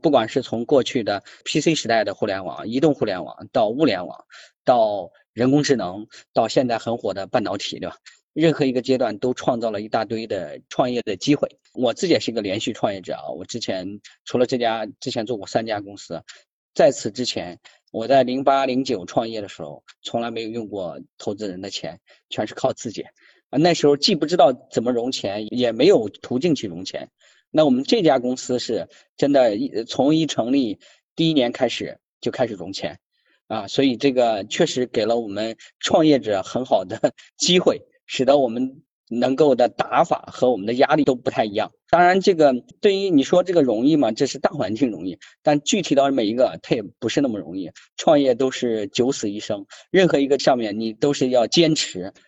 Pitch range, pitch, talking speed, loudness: 115-155 Hz, 135 Hz, 295 characters per minute, -21 LUFS